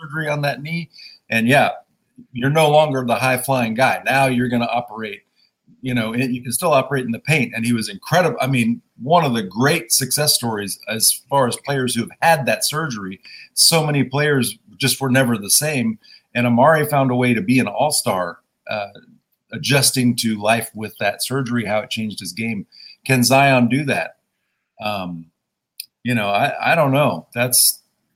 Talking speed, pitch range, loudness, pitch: 190 wpm, 115-135 Hz, -18 LUFS, 125 Hz